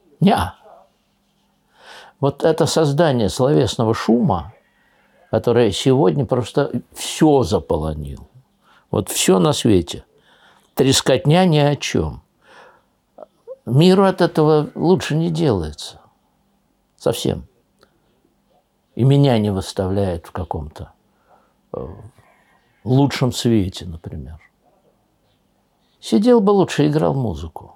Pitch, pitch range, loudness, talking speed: 130 Hz, 100-160 Hz, -17 LUFS, 85 wpm